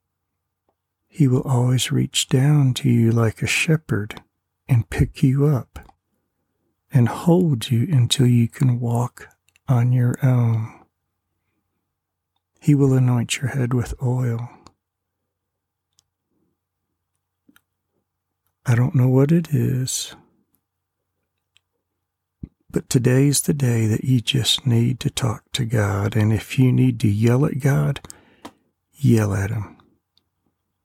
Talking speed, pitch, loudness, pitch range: 115 wpm, 115 Hz, -20 LUFS, 95-130 Hz